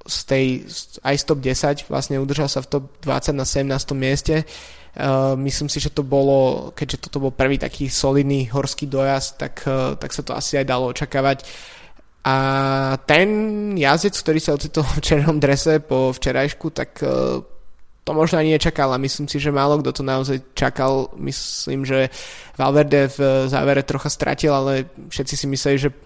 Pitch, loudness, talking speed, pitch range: 140 Hz, -20 LUFS, 170 wpm, 135-150 Hz